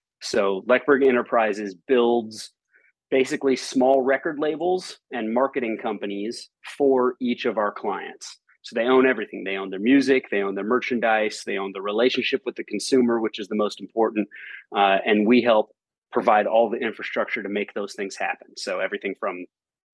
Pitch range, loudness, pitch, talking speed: 105-130 Hz, -23 LUFS, 120 Hz, 170 wpm